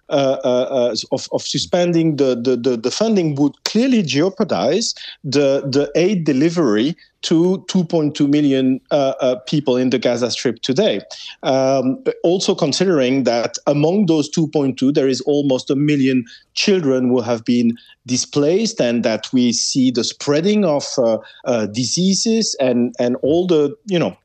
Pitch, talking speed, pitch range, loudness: 140 Hz, 155 wpm, 125-170 Hz, -17 LUFS